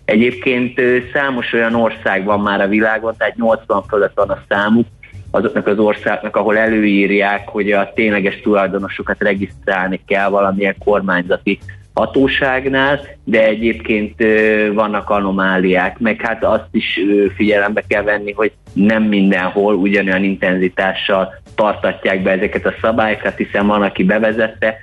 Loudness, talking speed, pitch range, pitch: -15 LUFS, 130 wpm, 100-110 Hz, 105 Hz